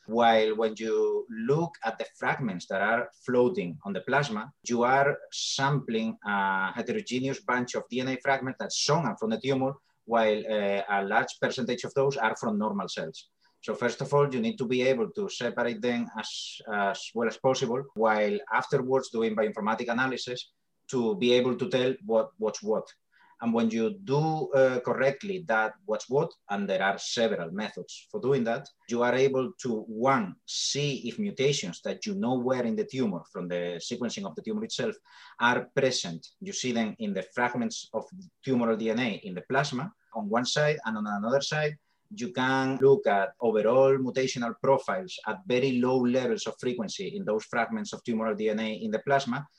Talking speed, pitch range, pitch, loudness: 180 wpm, 110-140 Hz, 125 Hz, -28 LUFS